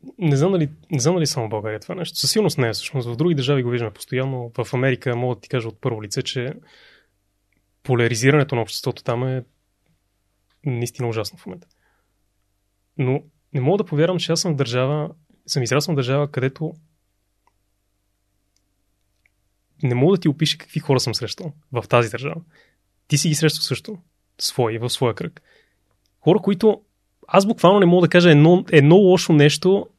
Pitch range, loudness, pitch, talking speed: 105-155 Hz, -19 LUFS, 130 Hz, 175 wpm